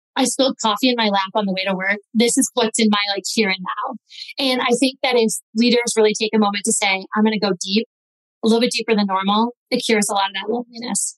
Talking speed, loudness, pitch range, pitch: 270 wpm, -18 LUFS, 205-240 Hz, 225 Hz